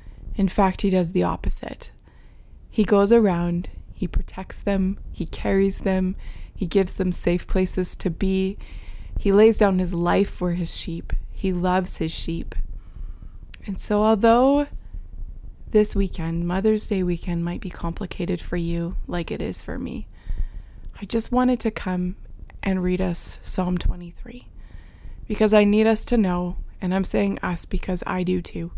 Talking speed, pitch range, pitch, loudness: 160 wpm, 170-200 Hz, 185 Hz, -23 LUFS